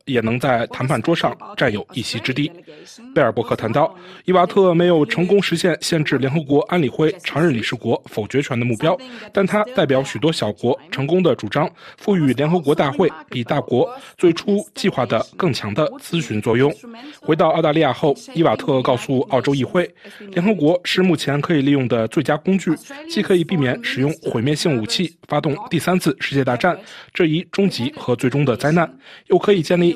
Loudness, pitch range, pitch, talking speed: -19 LUFS, 140-185 Hz, 160 Hz, 300 characters per minute